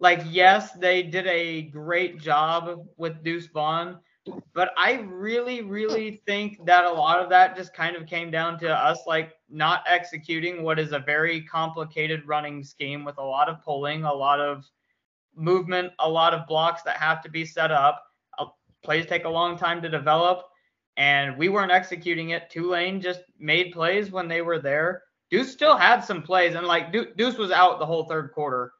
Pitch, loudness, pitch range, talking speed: 170 Hz, -23 LUFS, 160-180 Hz, 190 wpm